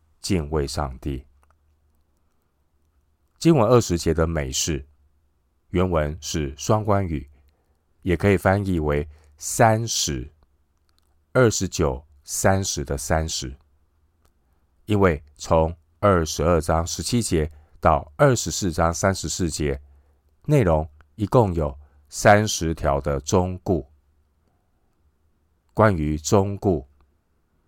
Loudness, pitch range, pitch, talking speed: -22 LUFS, 75-90 Hz, 80 Hz, 145 characters per minute